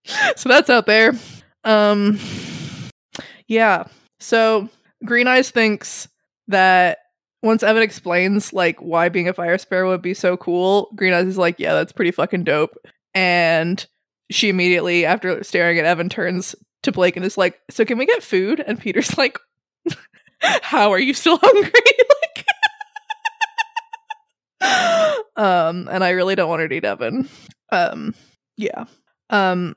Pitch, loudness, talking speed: 210 Hz, -17 LUFS, 145 wpm